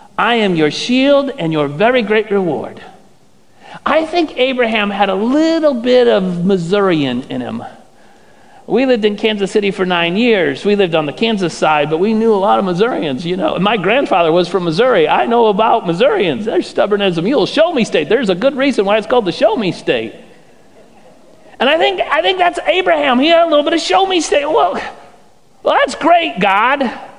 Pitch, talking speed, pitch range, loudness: 225 Hz, 205 wpm, 195-285 Hz, -13 LUFS